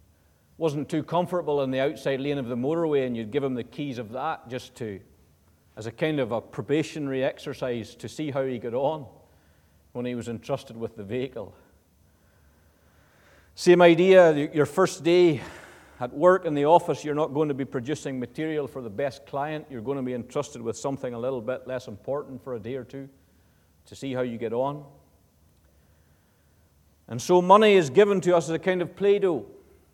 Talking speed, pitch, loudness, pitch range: 195 wpm, 130 Hz, -25 LUFS, 105-150 Hz